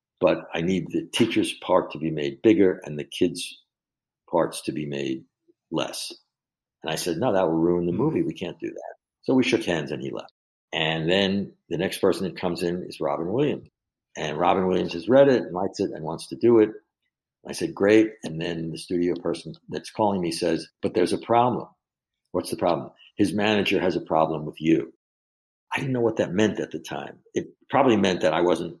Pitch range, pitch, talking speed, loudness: 80-110 Hz, 90 Hz, 215 wpm, -24 LUFS